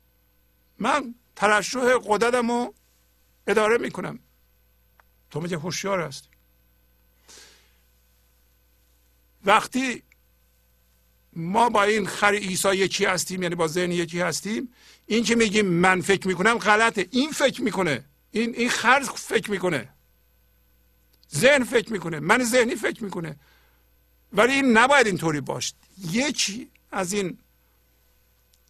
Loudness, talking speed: -23 LUFS, 110 wpm